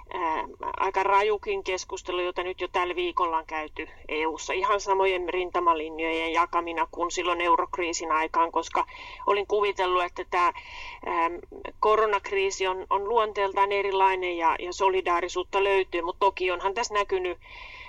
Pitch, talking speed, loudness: 195 Hz, 130 wpm, -26 LUFS